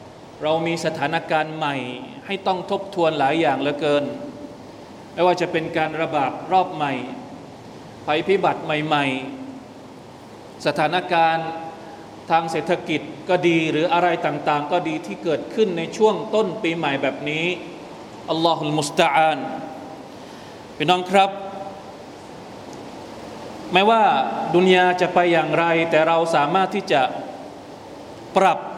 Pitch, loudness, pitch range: 165 Hz, -20 LUFS, 155-180 Hz